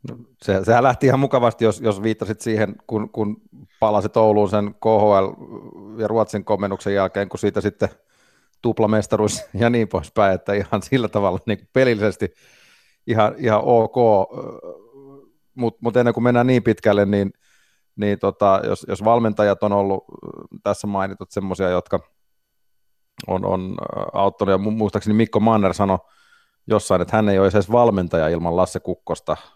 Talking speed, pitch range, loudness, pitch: 145 wpm, 100-115 Hz, -19 LUFS, 105 Hz